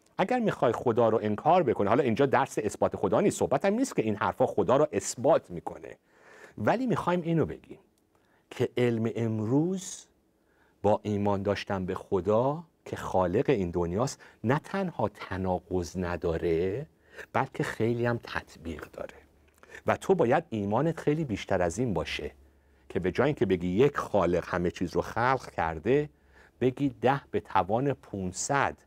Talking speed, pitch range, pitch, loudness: 150 wpm, 100-150 Hz, 120 Hz, -28 LUFS